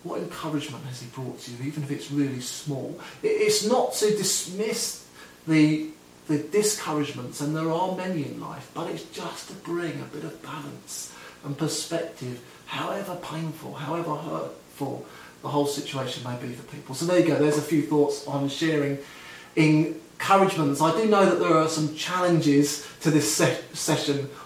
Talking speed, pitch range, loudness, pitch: 170 wpm, 140-165 Hz, -25 LUFS, 150 Hz